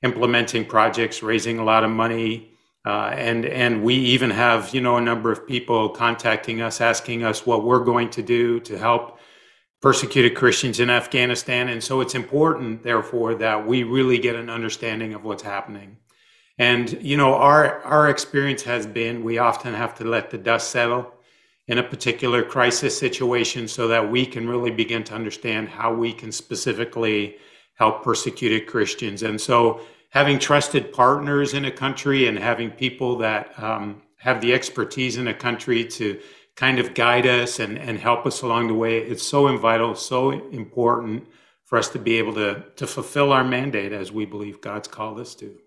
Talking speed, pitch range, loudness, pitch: 180 wpm, 115-125 Hz, -21 LUFS, 120 Hz